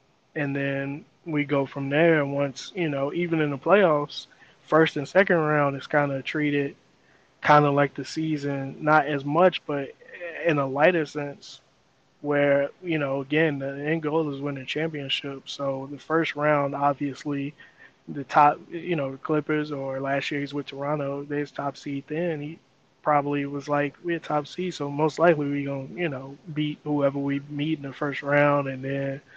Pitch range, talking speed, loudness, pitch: 140-155 Hz, 180 wpm, -25 LUFS, 145 Hz